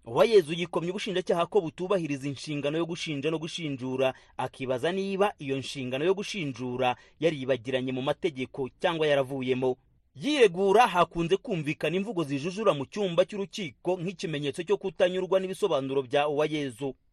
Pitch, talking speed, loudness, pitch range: 165 Hz, 130 wpm, -28 LUFS, 135-190 Hz